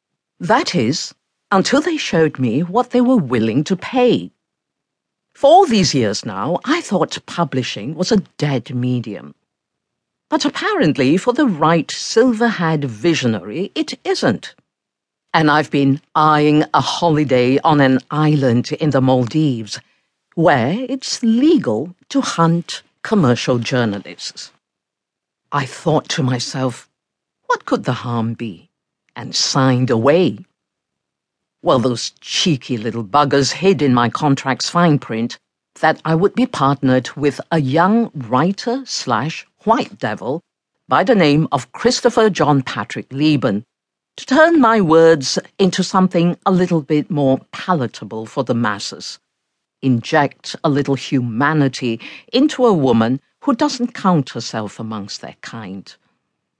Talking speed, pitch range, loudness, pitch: 130 wpm, 130-195 Hz, -16 LUFS, 150 Hz